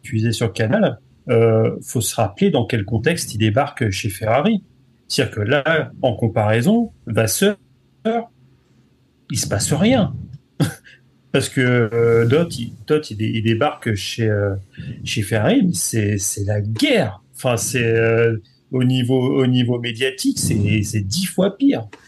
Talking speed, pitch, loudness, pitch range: 150 wpm, 120 Hz, -19 LUFS, 110-140 Hz